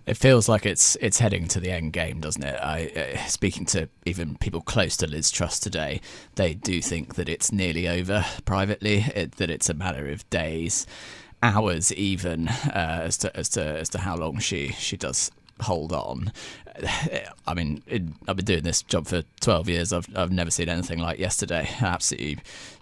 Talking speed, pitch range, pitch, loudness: 190 wpm, 80-100 Hz, 85 Hz, -25 LUFS